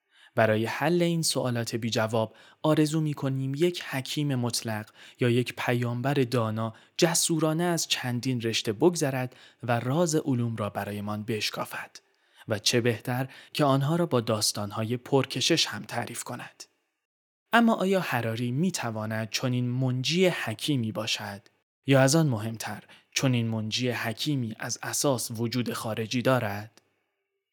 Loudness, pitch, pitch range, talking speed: -27 LUFS, 125 Hz, 115-145 Hz, 135 wpm